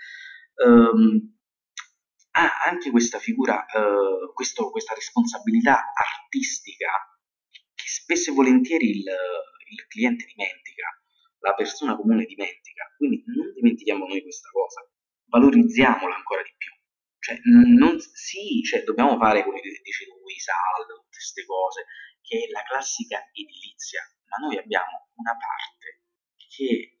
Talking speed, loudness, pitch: 125 wpm, -22 LUFS, 350 Hz